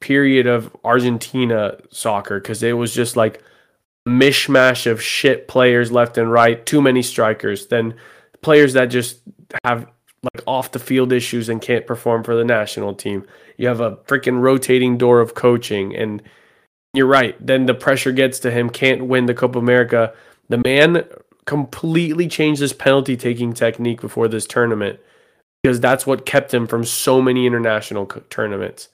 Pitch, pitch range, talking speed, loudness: 125 Hz, 115-130 Hz, 170 wpm, -17 LUFS